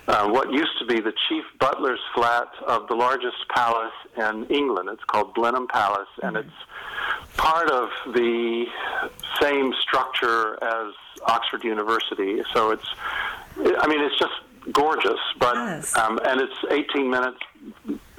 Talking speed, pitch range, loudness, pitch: 140 wpm, 115-145 Hz, -23 LUFS, 120 Hz